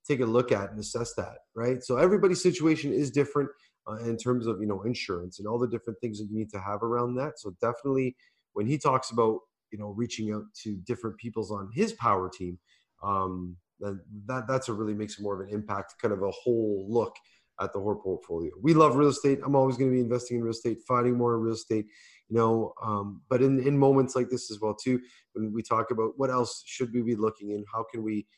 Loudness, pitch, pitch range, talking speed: -29 LUFS, 115 Hz, 105-130 Hz, 235 wpm